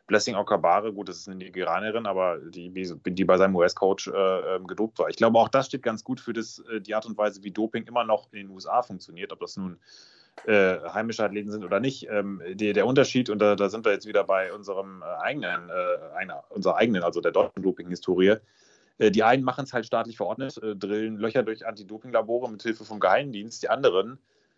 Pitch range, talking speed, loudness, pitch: 100-115 Hz, 220 wpm, -26 LUFS, 110 Hz